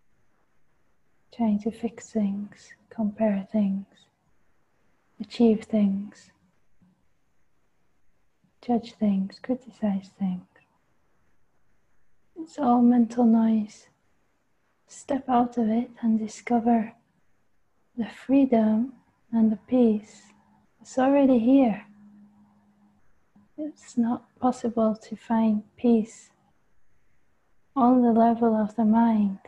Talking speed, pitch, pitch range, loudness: 85 wpm, 225 Hz, 210-240 Hz, -24 LUFS